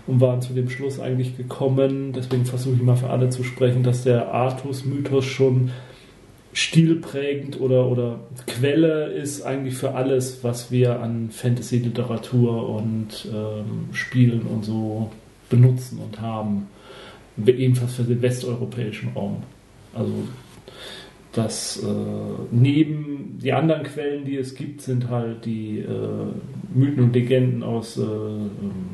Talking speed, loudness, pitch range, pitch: 135 wpm, -23 LUFS, 115-130 Hz, 125 Hz